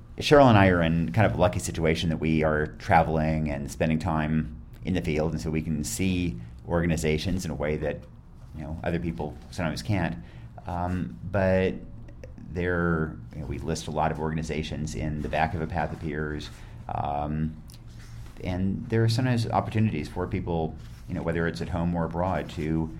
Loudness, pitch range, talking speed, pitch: -27 LUFS, 75-90 Hz, 190 wpm, 80 Hz